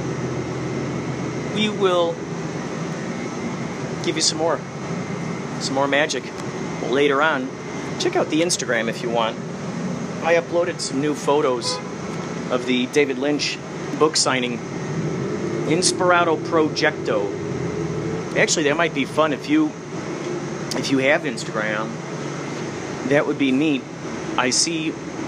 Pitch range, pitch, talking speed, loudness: 145-180 Hz, 170 Hz, 115 wpm, -22 LUFS